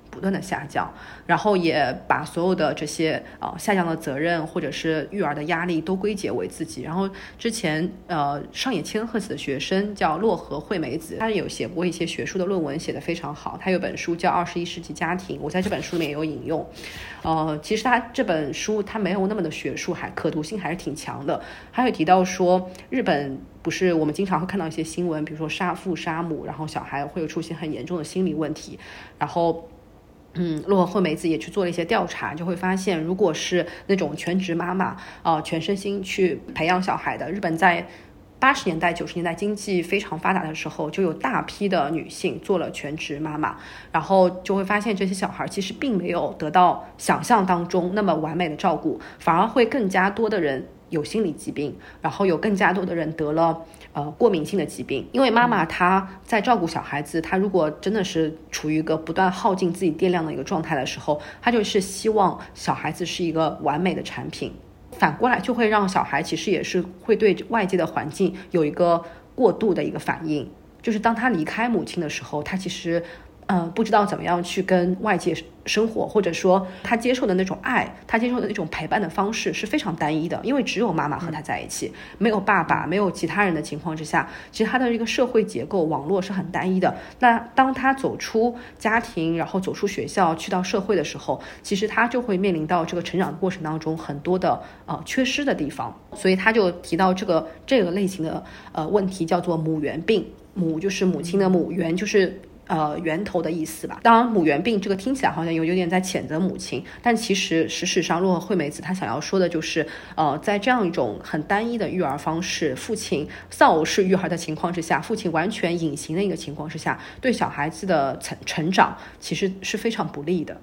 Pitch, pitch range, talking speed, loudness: 180 Hz, 160-200 Hz, 320 characters per minute, -23 LUFS